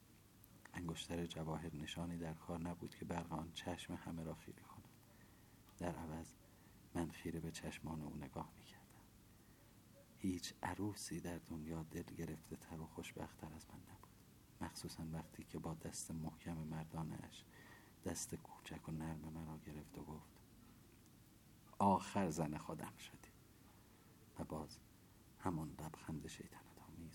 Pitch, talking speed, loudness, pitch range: 85 Hz, 130 wpm, -48 LUFS, 80-100 Hz